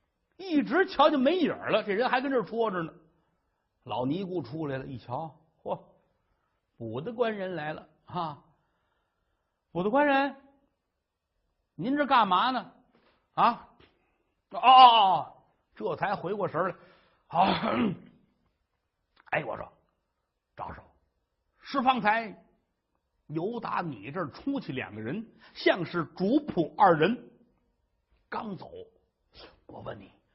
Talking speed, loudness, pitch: 160 characters per minute, -27 LUFS, 205 Hz